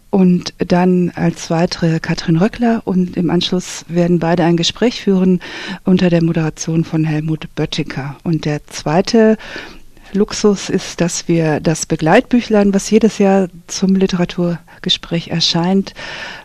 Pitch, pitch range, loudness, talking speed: 175 Hz, 165-195 Hz, -15 LUFS, 130 wpm